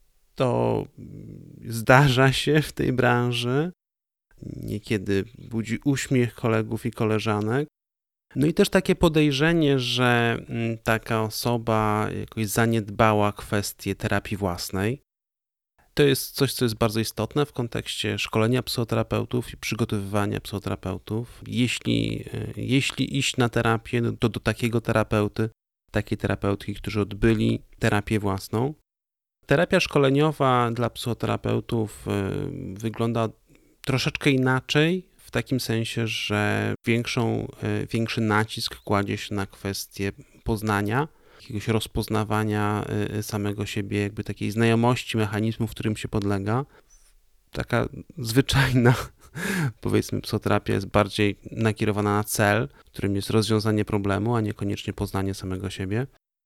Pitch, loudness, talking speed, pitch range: 115 Hz, -25 LUFS, 110 wpm, 105-125 Hz